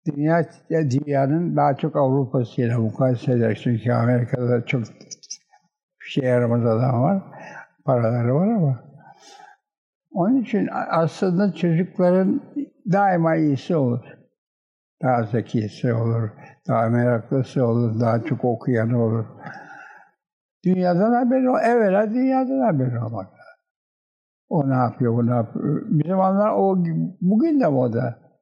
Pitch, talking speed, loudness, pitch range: 140 Hz, 115 wpm, -21 LUFS, 120-195 Hz